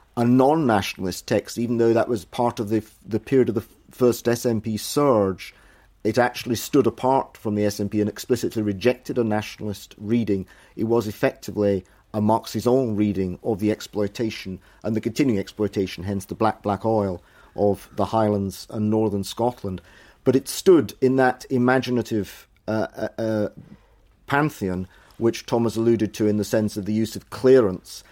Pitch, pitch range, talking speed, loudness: 110 Hz, 100-120 Hz, 160 wpm, -23 LUFS